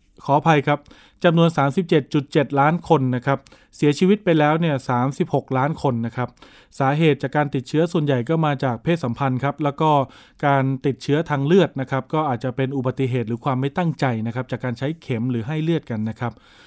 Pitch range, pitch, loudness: 130-155 Hz, 140 Hz, -21 LUFS